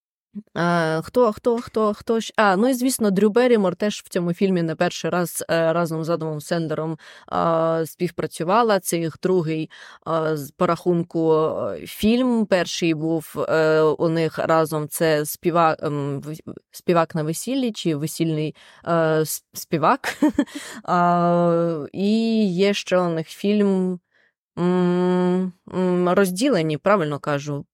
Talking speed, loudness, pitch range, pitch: 115 wpm, -21 LUFS, 160-200 Hz, 175 Hz